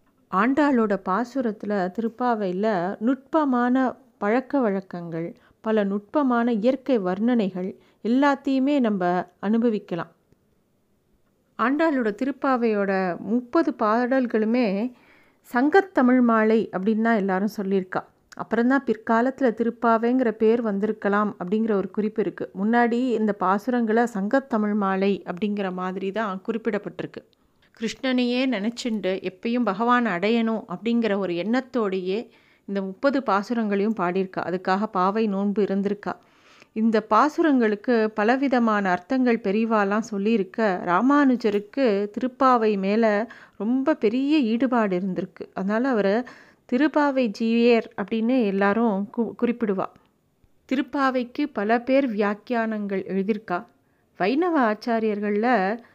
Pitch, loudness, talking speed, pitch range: 225 Hz, -23 LUFS, 95 wpm, 200-245 Hz